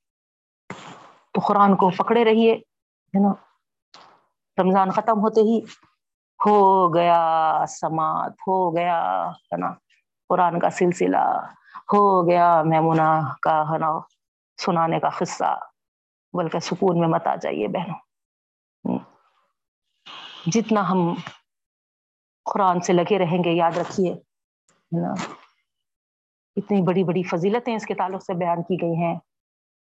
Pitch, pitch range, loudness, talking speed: 180 Hz, 160-195 Hz, -21 LUFS, 130 wpm